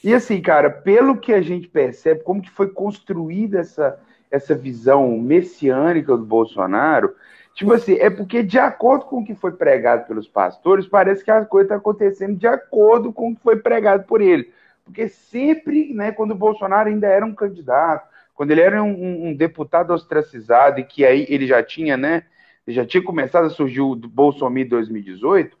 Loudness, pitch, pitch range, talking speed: -17 LUFS, 195 Hz, 145-220 Hz, 185 wpm